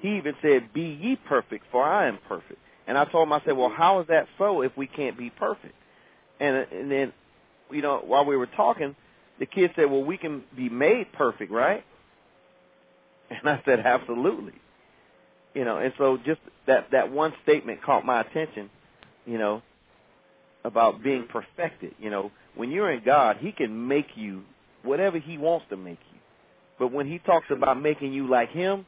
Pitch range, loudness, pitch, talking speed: 125-160 Hz, -25 LUFS, 140 Hz, 190 wpm